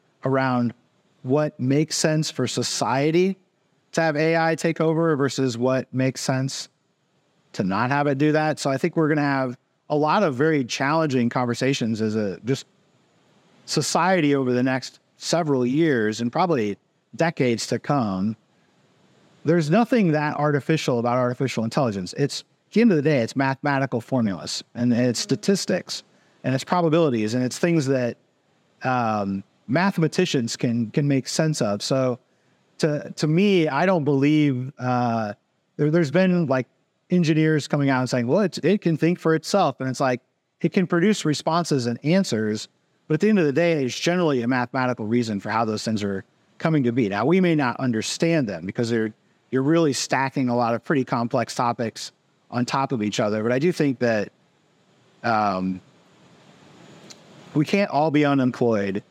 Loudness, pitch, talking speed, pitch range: -22 LUFS, 140 Hz, 170 wpm, 120-160 Hz